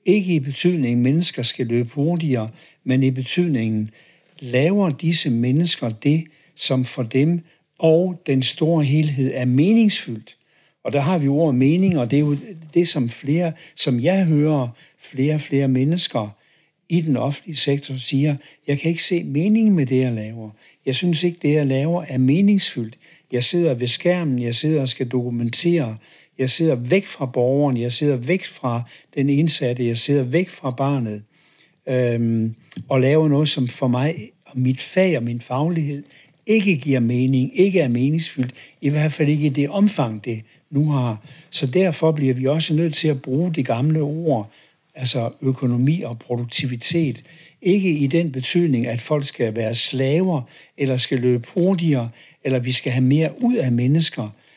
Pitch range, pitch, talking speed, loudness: 125-165 Hz, 140 Hz, 175 wpm, -19 LUFS